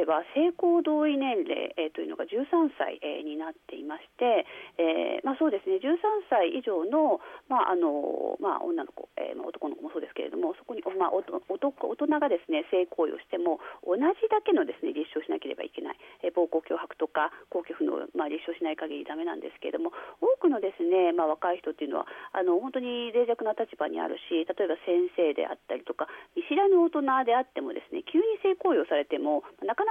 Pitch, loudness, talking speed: 305 Hz, -29 LUFS, 390 characters per minute